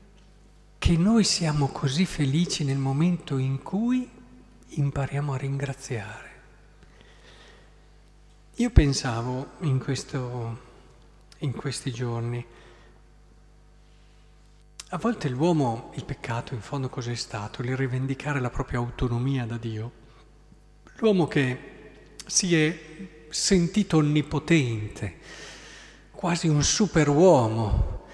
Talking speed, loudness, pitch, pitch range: 95 wpm, -26 LUFS, 140 Hz, 125-165 Hz